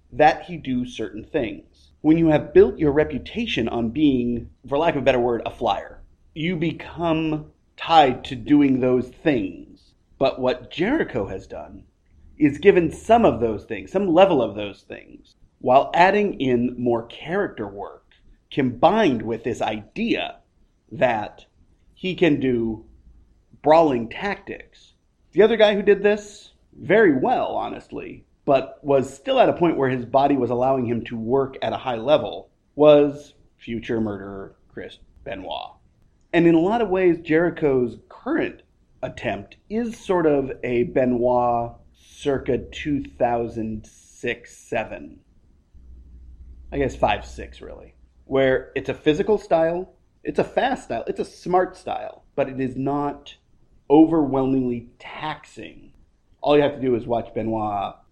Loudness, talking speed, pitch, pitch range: -21 LUFS, 145 wpm, 135 Hz, 115-165 Hz